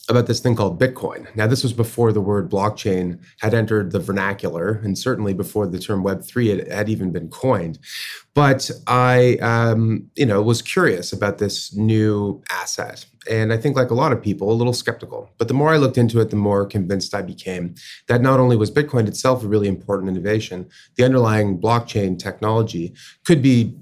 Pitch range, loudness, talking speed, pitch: 100-125 Hz, -19 LUFS, 195 wpm, 110 Hz